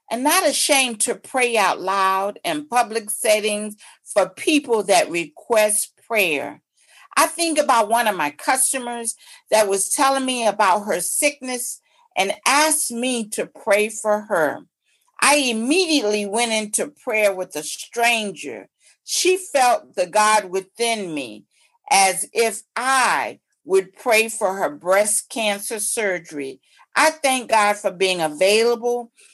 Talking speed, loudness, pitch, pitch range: 135 wpm, -19 LUFS, 230 Hz, 210-275 Hz